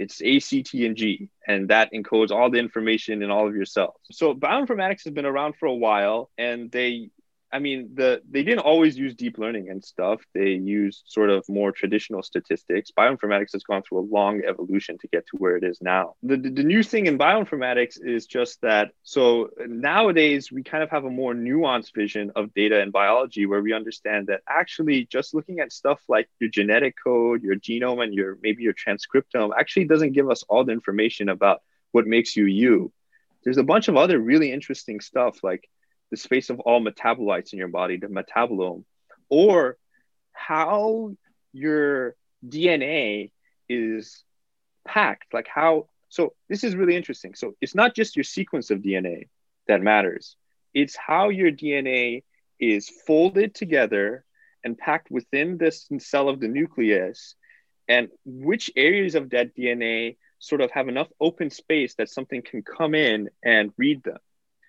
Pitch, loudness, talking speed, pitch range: 125 Hz, -23 LUFS, 180 wpm, 105-160 Hz